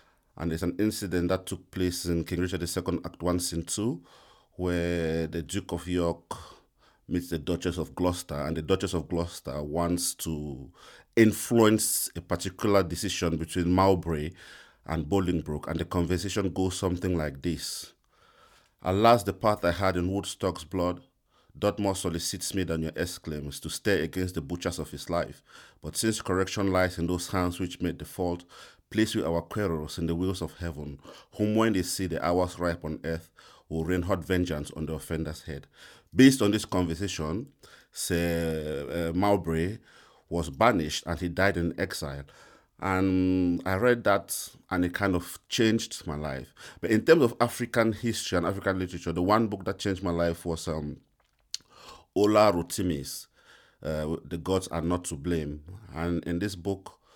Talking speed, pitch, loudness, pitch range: 170 wpm, 90 Hz, -28 LUFS, 85-95 Hz